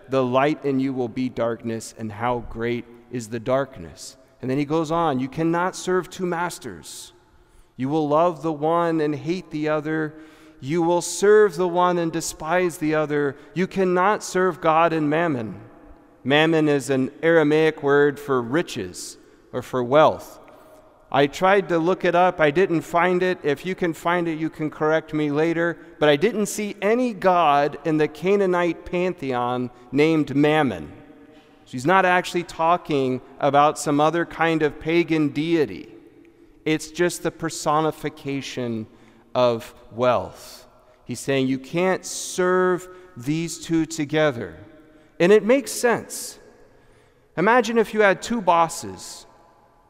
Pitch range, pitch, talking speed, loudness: 140-175 Hz, 155 Hz, 150 wpm, -22 LUFS